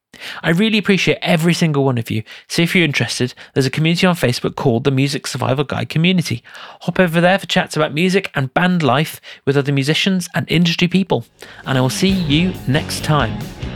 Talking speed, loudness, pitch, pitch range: 200 wpm, -16 LUFS, 160 Hz, 135-180 Hz